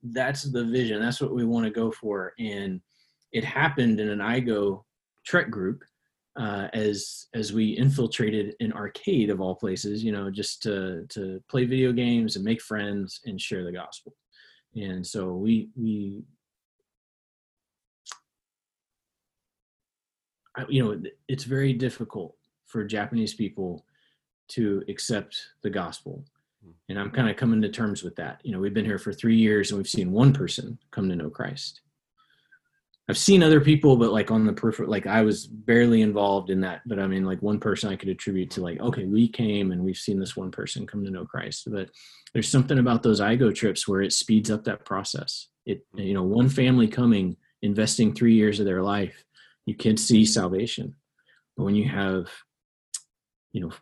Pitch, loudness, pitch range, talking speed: 110 Hz, -25 LUFS, 100-120 Hz, 180 wpm